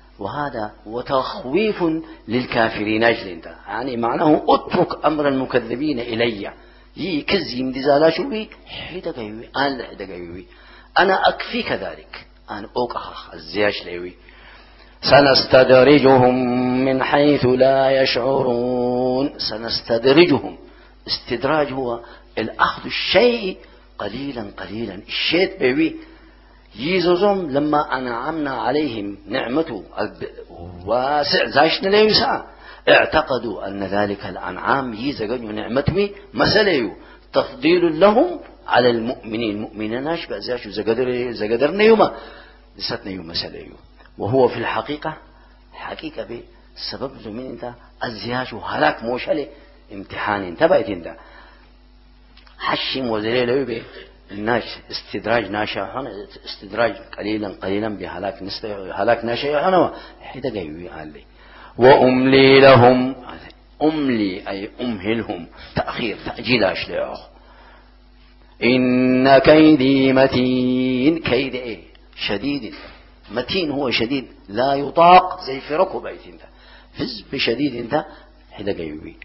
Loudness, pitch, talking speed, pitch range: -18 LUFS, 125 Hz, 90 wpm, 110-150 Hz